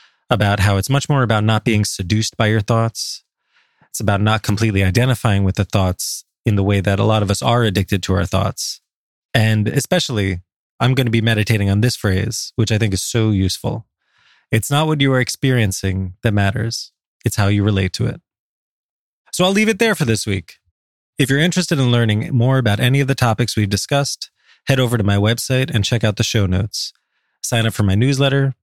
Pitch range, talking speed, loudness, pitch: 100-125 Hz, 210 wpm, -17 LUFS, 110 Hz